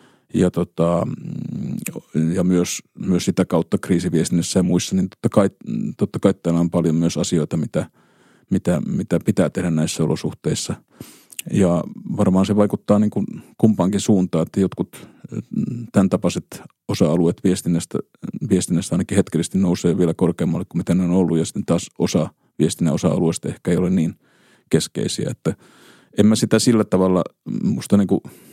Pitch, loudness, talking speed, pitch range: 90 Hz, -20 LUFS, 150 wpm, 85-100 Hz